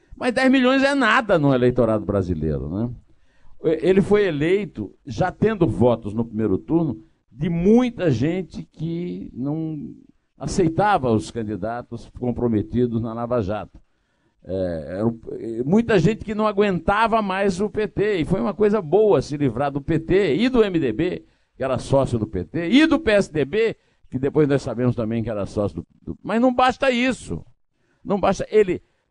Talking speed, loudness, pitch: 160 wpm, -21 LUFS, 155 Hz